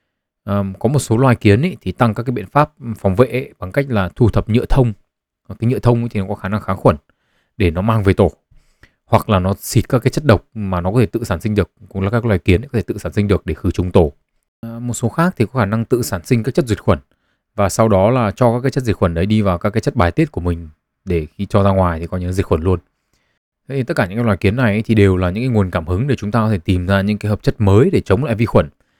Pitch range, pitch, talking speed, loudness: 95-120 Hz, 105 Hz, 310 wpm, -17 LUFS